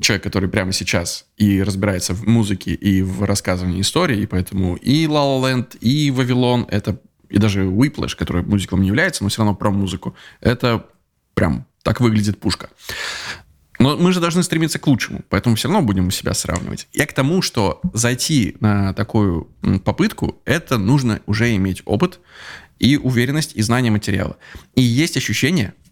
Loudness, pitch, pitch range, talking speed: -18 LUFS, 105 Hz, 100-130 Hz, 170 wpm